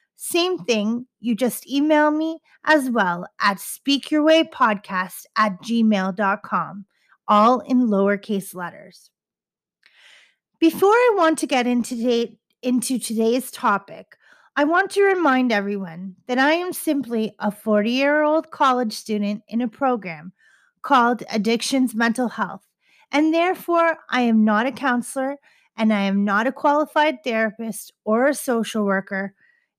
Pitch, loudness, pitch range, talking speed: 240 Hz, -20 LUFS, 210-300 Hz, 130 wpm